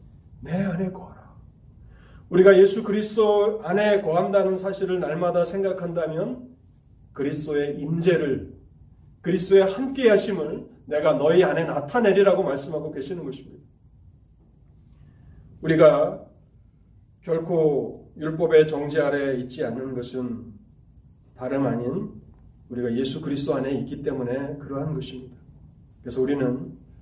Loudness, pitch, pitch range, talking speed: -23 LUFS, 155 Hz, 130-190 Hz, 280 characters per minute